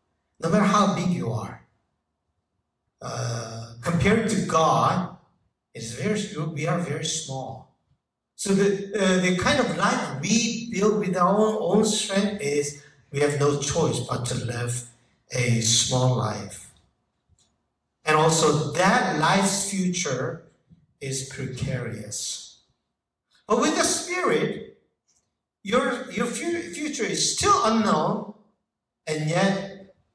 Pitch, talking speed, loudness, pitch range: 165 Hz, 120 wpm, -24 LUFS, 130-210 Hz